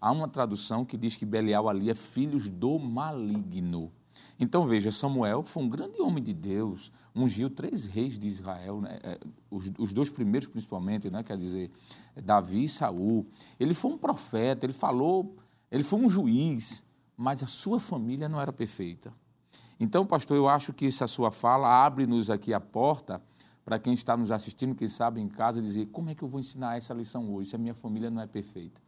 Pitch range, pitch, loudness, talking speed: 105-135 Hz, 115 Hz, -29 LUFS, 195 wpm